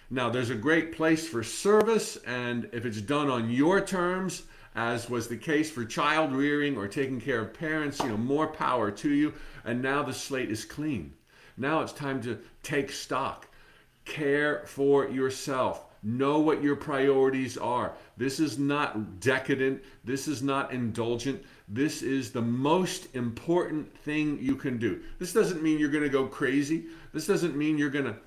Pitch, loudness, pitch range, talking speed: 140 Hz, -29 LUFS, 125-155 Hz, 175 wpm